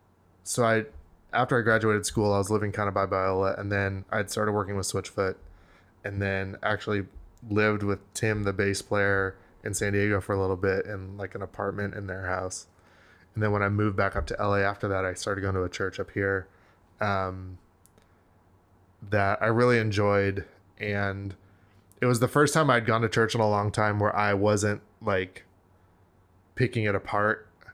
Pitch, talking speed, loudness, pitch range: 100 Hz, 190 wpm, -27 LUFS, 95-105 Hz